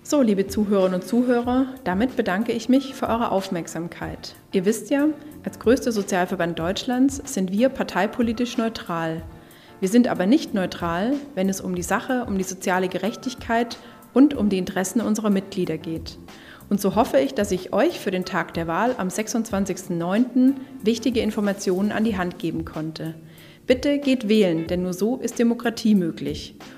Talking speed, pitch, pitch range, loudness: 165 wpm, 205 Hz, 180-240 Hz, -23 LUFS